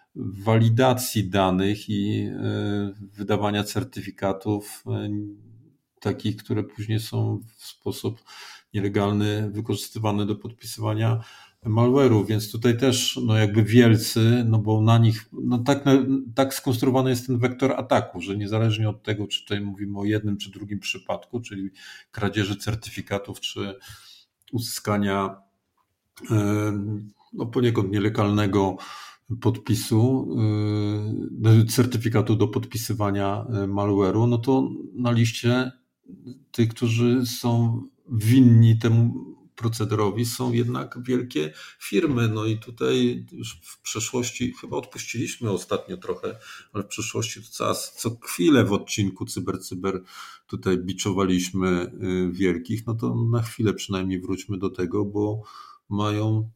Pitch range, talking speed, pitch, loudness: 100-120 Hz, 120 wpm, 110 Hz, -24 LUFS